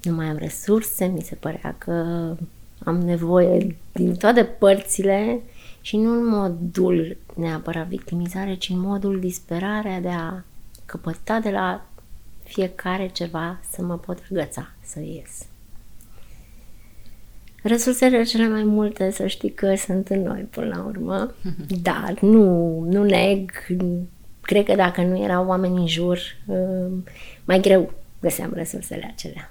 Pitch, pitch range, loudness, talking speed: 180 Hz, 170-195 Hz, -22 LUFS, 135 wpm